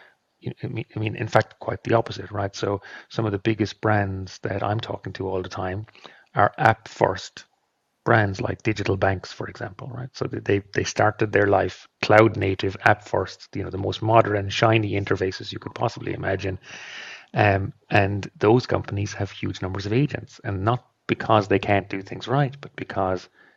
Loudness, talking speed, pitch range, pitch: -24 LUFS, 180 wpm, 95-115 Hz, 105 Hz